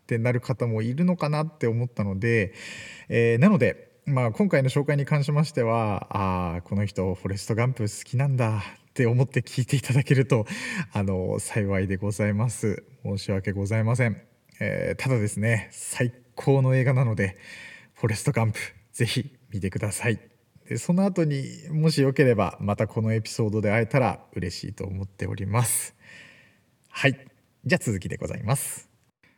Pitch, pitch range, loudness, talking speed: 115 Hz, 105-135 Hz, -25 LUFS, 345 characters per minute